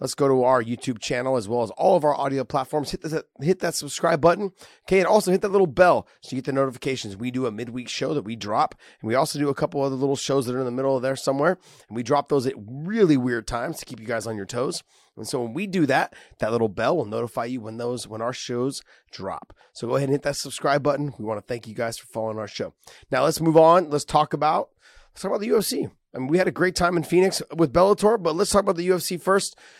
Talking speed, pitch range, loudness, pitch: 280 wpm, 125-165 Hz, -23 LUFS, 140 Hz